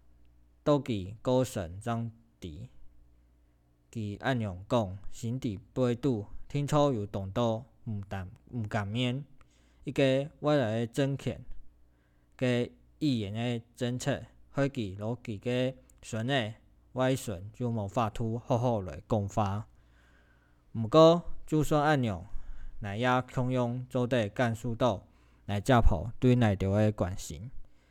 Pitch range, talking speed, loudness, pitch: 95-125 Hz, 175 characters per minute, -31 LUFS, 115 Hz